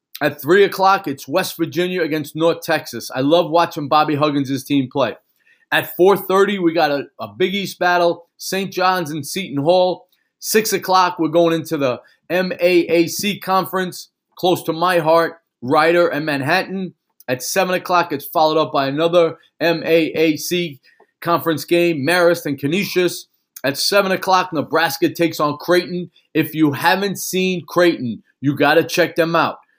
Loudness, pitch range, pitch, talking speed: -17 LUFS, 155-185 Hz, 170 Hz, 155 wpm